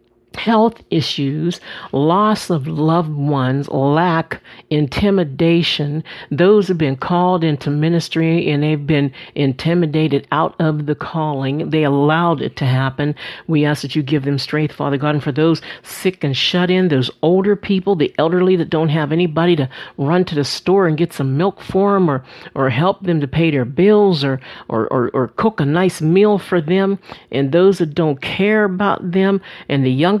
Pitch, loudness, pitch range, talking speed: 160 Hz, -16 LUFS, 145-180 Hz, 180 wpm